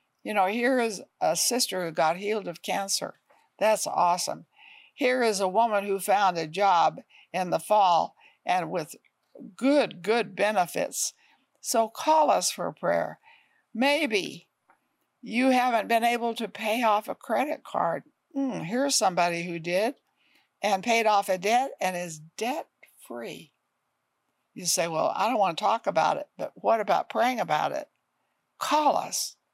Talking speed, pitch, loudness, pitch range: 160 wpm, 225 Hz, -26 LUFS, 195-265 Hz